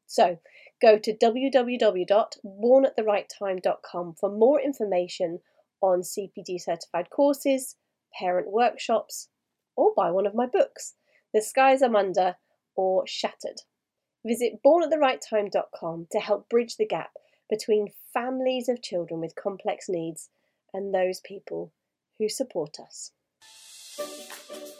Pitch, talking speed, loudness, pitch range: 215 Hz, 110 wpm, -25 LUFS, 190-260 Hz